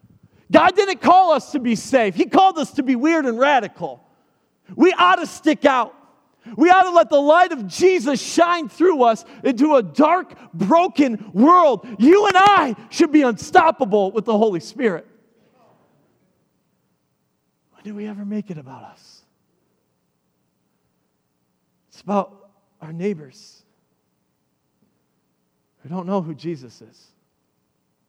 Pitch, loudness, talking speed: 245 Hz, -17 LUFS, 135 wpm